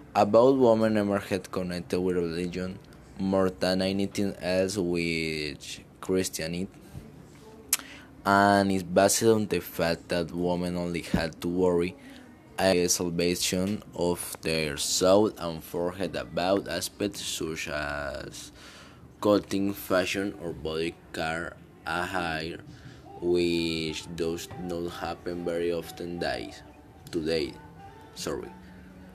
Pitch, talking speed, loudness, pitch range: 90 Hz, 105 wpm, -28 LUFS, 85-95 Hz